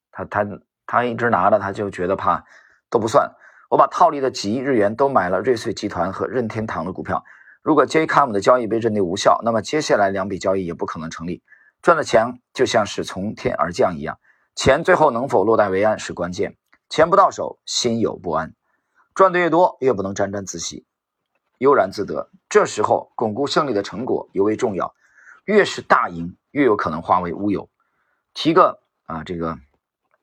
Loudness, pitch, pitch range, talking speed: -19 LUFS, 100 Hz, 85-120 Hz, 290 characters per minute